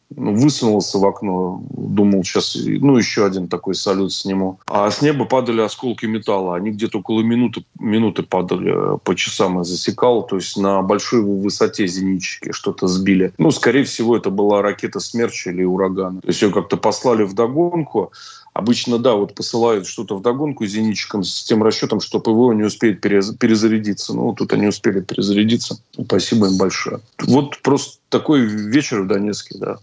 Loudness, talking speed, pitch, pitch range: -18 LUFS, 165 wpm, 105 Hz, 95-115 Hz